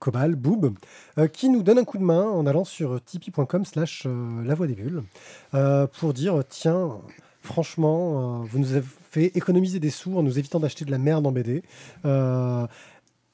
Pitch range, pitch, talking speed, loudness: 135-170 Hz, 150 Hz, 190 wpm, -24 LUFS